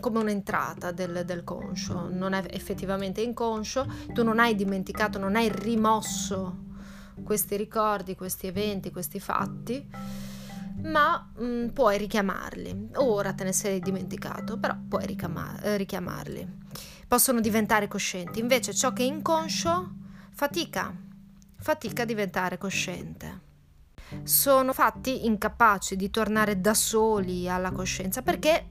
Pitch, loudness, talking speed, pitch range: 195 Hz, -27 LUFS, 120 wpm, 185-220 Hz